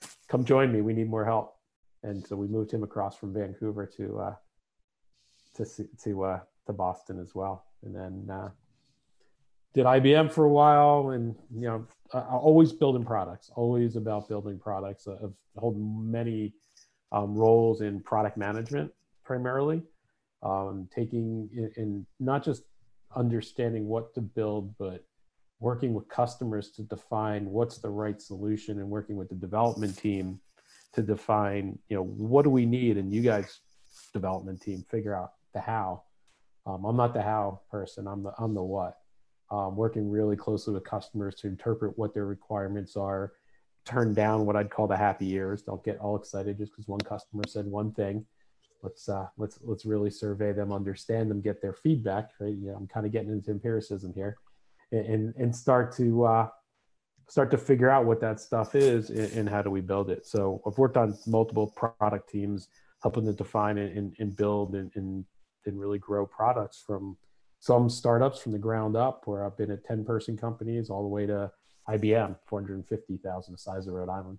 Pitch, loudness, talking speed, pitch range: 105 Hz, -29 LUFS, 180 wpm, 100-115 Hz